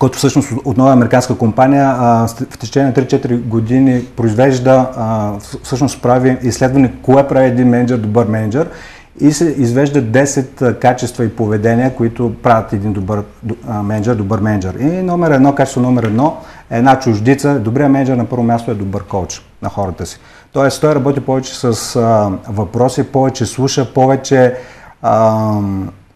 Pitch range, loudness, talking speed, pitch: 110-135 Hz, -13 LUFS, 160 wpm, 125 Hz